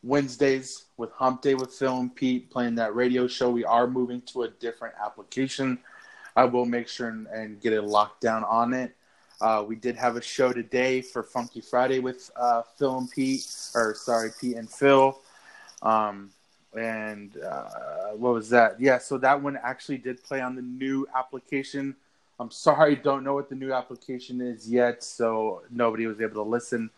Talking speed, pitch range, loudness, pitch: 185 wpm, 115-130 Hz, -26 LUFS, 125 Hz